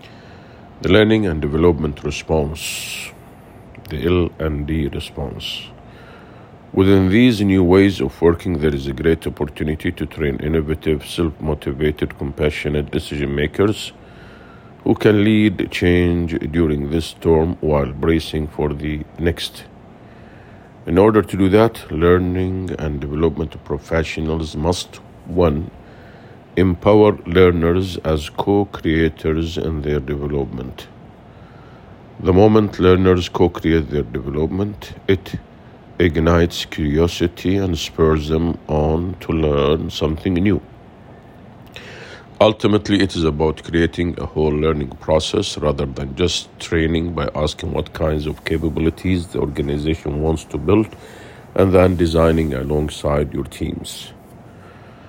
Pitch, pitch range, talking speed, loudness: 80 Hz, 75-95 Hz, 115 wpm, -18 LUFS